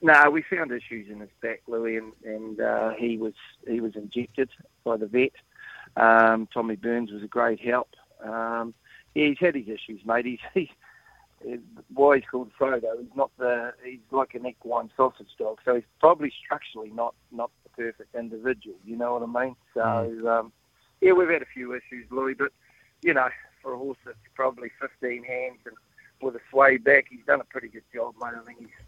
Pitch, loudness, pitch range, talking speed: 120 Hz, -26 LUFS, 115-130 Hz, 200 wpm